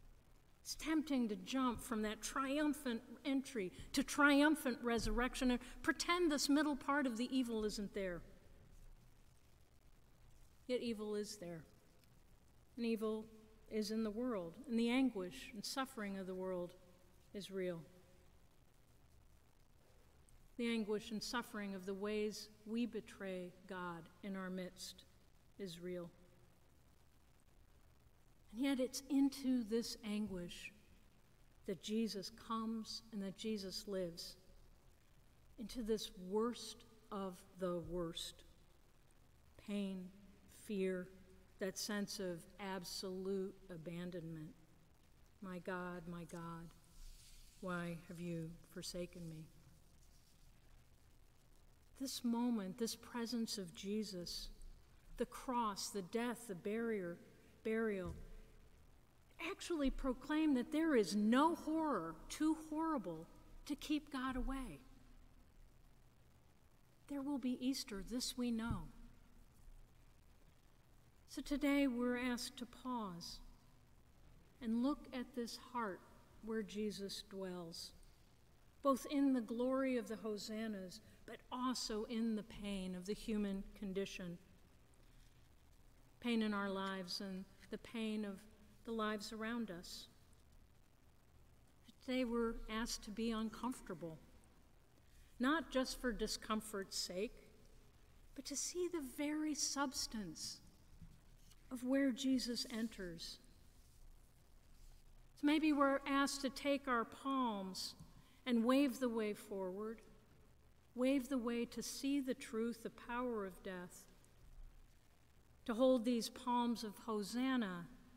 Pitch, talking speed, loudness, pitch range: 215 Hz, 110 wpm, -42 LUFS, 175-245 Hz